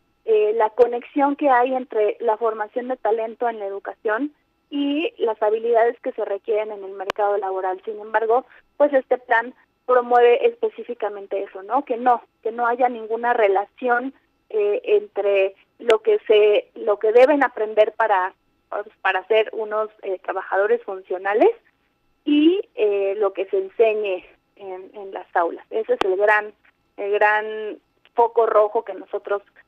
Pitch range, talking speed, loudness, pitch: 205-265 Hz, 150 wpm, -21 LUFS, 225 Hz